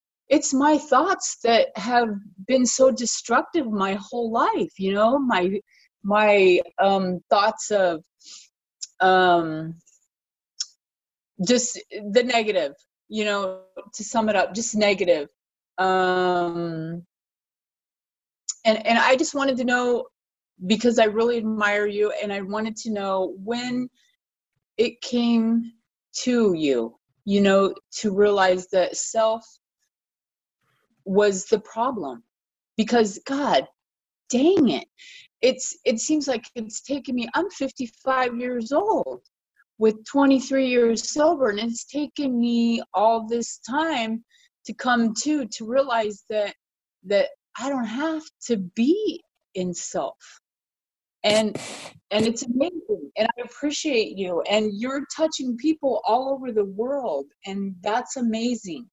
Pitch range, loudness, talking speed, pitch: 200-265 Hz, -23 LUFS, 125 wpm, 230 Hz